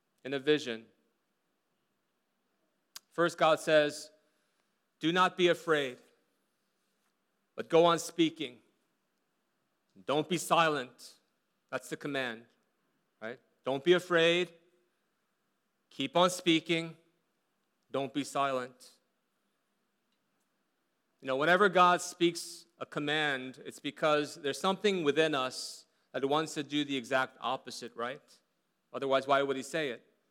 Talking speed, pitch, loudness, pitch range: 115 wpm, 155 Hz, -31 LUFS, 135-170 Hz